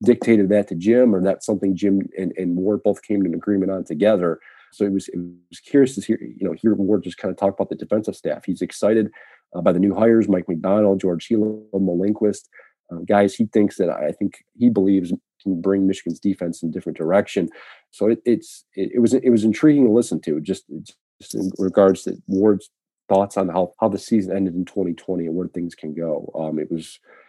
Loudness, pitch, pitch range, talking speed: -20 LUFS, 100 Hz, 90-110 Hz, 225 wpm